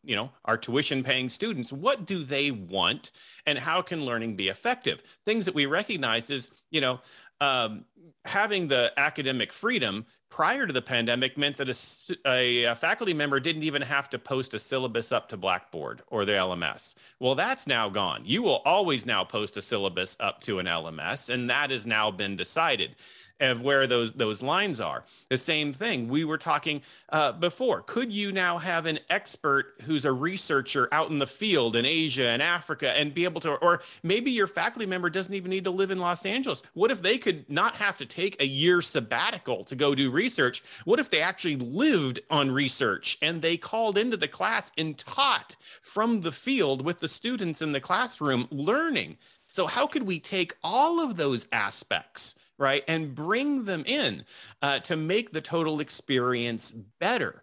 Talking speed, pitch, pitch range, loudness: 190 wpm, 150 Hz, 130-180 Hz, -27 LUFS